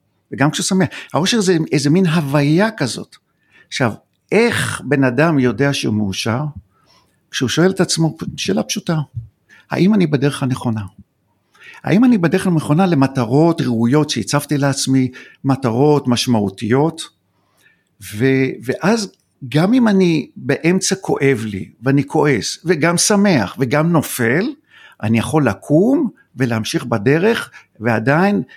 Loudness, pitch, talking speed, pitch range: -16 LUFS, 145 Hz, 120 wpm, 125-175 Hz